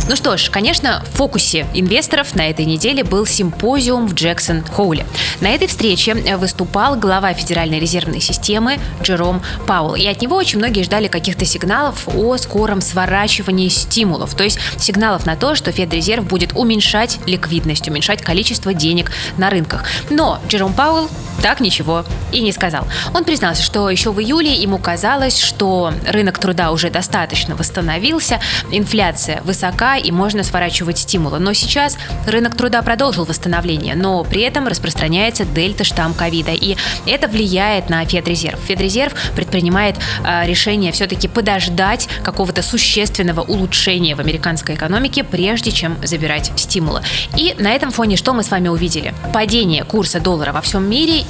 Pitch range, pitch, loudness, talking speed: 170-220 Hz, 190 Hz, -14 LUFS, 150 wpm